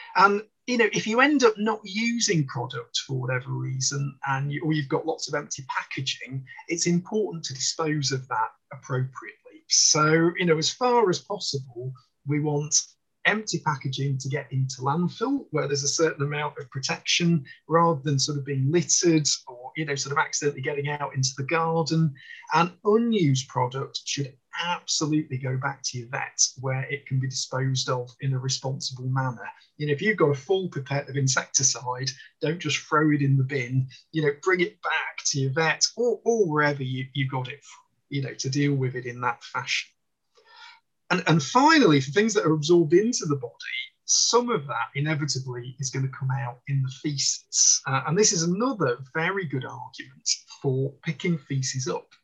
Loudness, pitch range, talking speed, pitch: -25 LUFS, 135-170 Hz, 190 wpm, 145 Hz